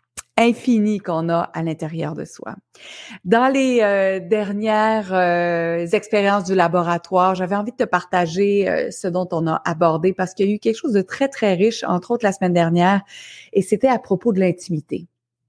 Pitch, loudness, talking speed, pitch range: 190 Hz, -19 LUFS, 185 wpm, 175-215 Hz